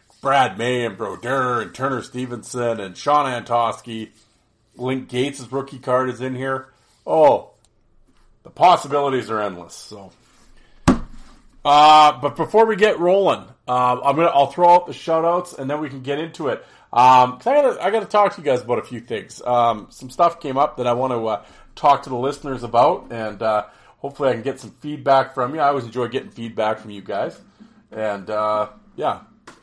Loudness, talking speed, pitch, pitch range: -19 LUFS, 190 wpm, 130 Hz, 115-145 Hz